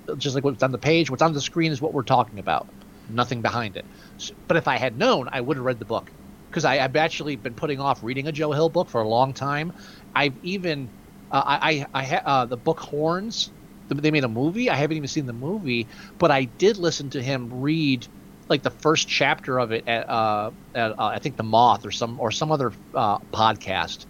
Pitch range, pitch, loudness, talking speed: 120-155 Hz, 140 Hz, -23 LUFS, 230 wpm